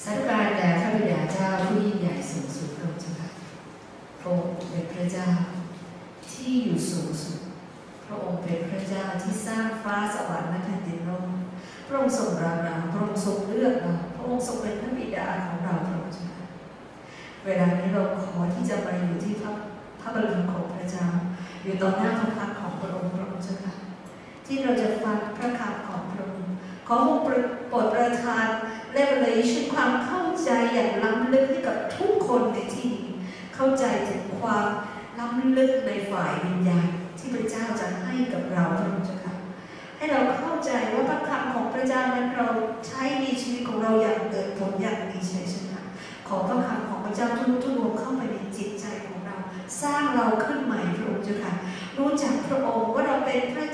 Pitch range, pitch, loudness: 185-245 Hz, 210 Hz, -27 LUFS